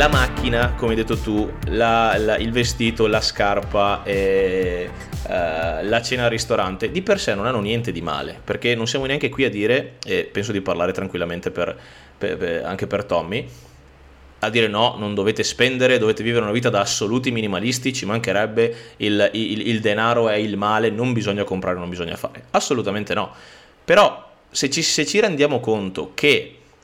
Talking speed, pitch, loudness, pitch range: 185 wpm, 110 Hz, -20 LUFS, 100-120 Hz